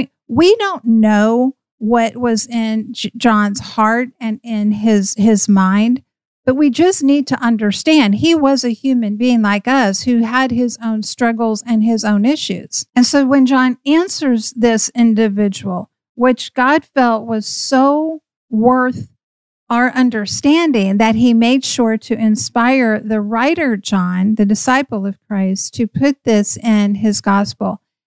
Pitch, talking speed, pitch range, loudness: 230 Hz, 150 wpm, 215-255 Hz, -14 LUFS